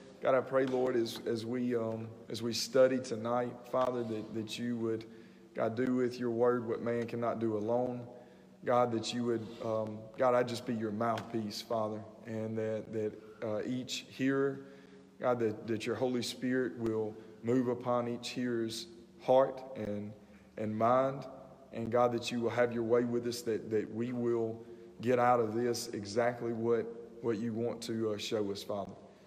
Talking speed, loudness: 180 wpm, -34 LUFS